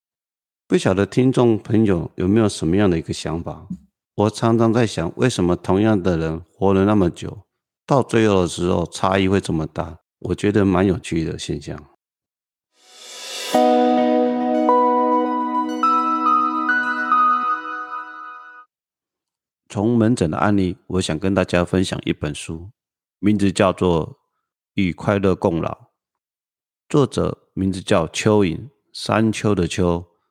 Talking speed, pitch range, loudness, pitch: 180 characters per minute, 85-115 Hz, -19 LUFS, 95 Hz